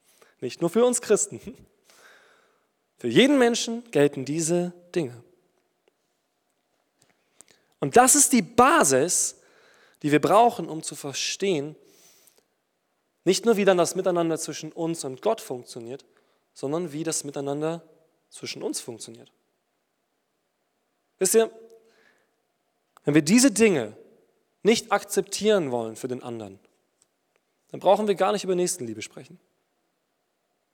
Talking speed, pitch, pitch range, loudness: 115 wpm, 180 Hz, 150-220 Hz, -23 LUFS